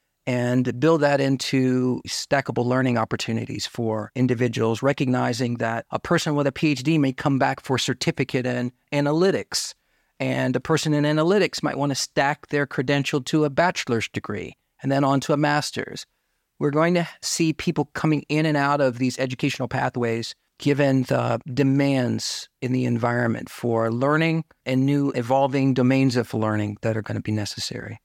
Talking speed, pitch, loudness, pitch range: 165 wpm, 135 Hz, -23 LUFS, 120-145 Hz